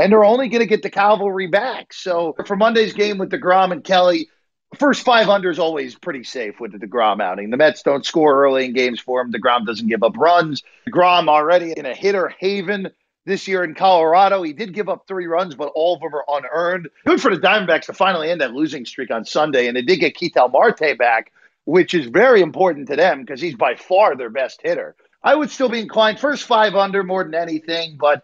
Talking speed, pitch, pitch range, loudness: 225 wpm, 190 Hz, 165-220 Hz, -17 LUFS